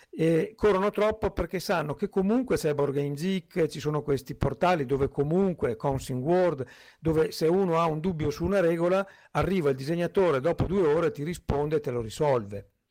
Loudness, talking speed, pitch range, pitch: -27 LUFS, 180 wpm, 145-190 Hz, 160 Hz